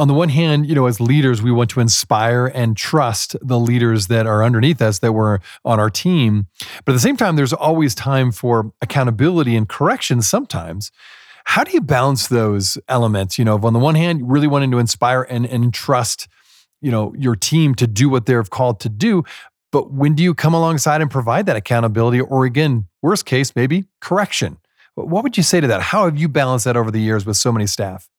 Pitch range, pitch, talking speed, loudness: 115-150 Hz, 125 Hz, 220 wpm, -16 LUFS